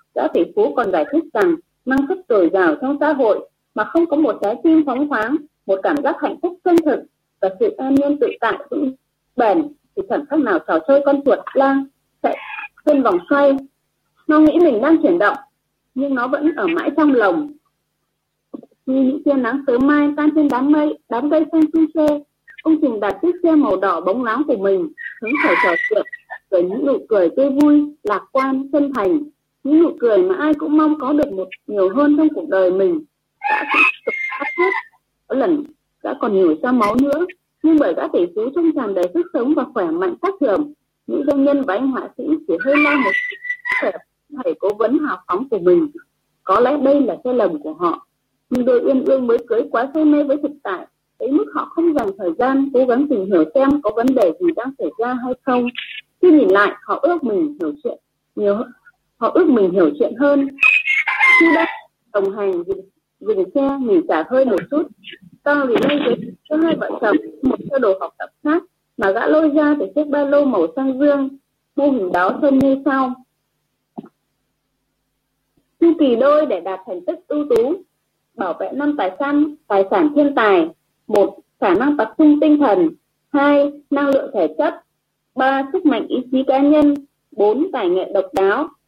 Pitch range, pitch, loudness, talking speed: 260-320 Hz, 290 Hz, -17 LUFS, 205 wpm